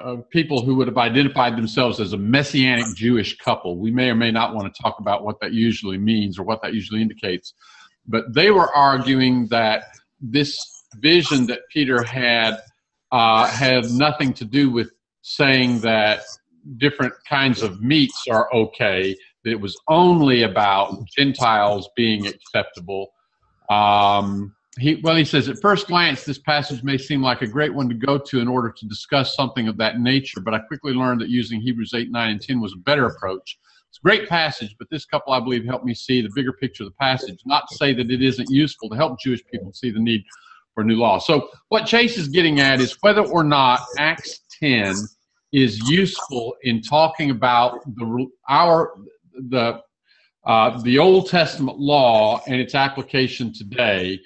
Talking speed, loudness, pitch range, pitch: 185 wpm, -19 LUFS, 115-140 Hz, 125 Hz